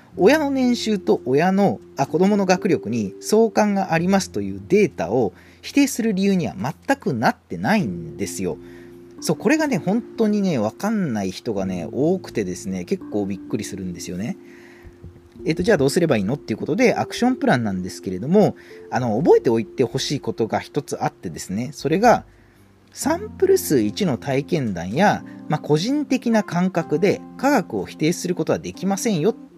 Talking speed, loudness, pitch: 365 characters per minute, -21 LUFS, 180 Hz